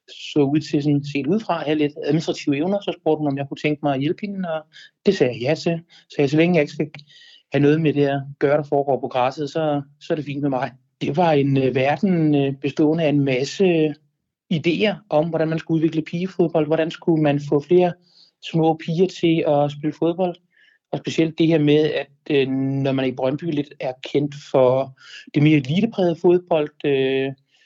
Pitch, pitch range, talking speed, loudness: 150 Hz, 140-165 Hz, 220 wpm, -21 LUFS